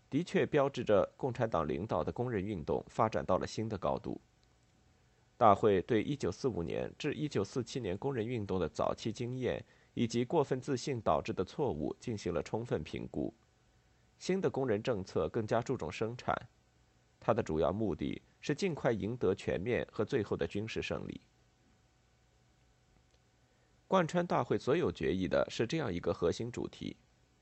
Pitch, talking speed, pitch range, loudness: 115 Hz, 250 characters per minute, 95-135 Hz, -35 LUFS